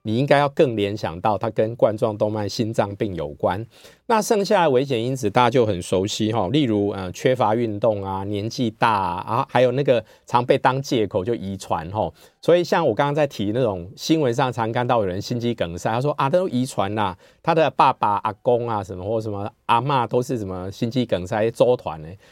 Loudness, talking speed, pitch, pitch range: -21 LUFS, 315 characters per minute, 115 Hz, 100-125 Hz